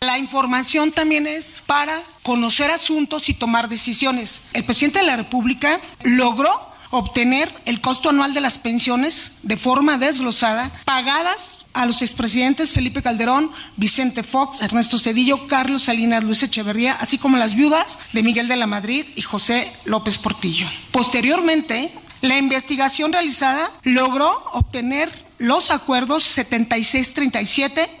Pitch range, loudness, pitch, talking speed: 240-300 Hz, -18 LUFS, 260 Hz, 135 wpm